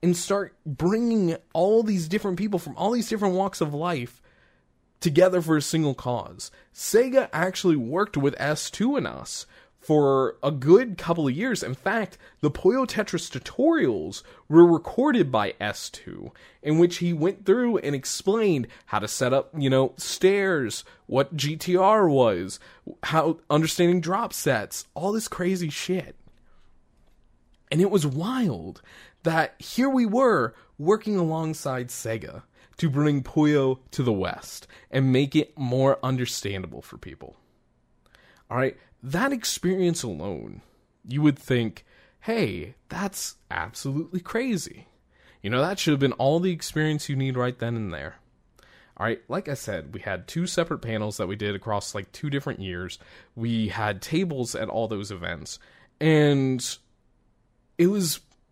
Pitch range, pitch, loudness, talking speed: 125-185 Hz, 150 Hz, -25 LUFS, 150 wpm